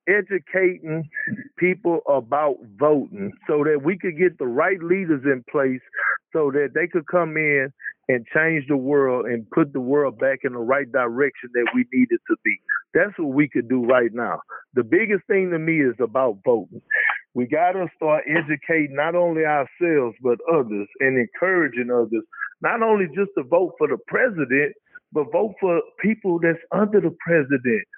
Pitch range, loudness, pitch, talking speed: 140-200 Hz, -21 LUFS, 165 Hz, 175 wpm